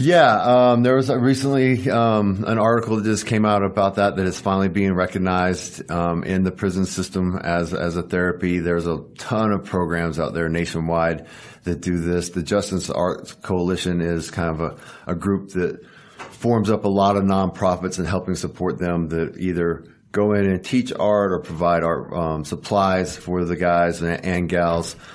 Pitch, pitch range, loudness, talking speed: 90 Hz, 85-100 Hz, -21 LUFS, 190 wpm